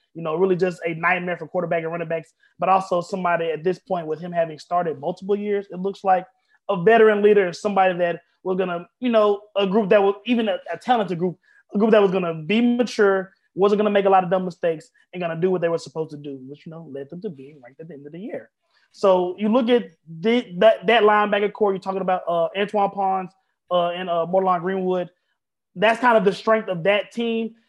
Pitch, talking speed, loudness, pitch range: 190 Hz, 240 wpm, -21 LUFS, 170-210 Hz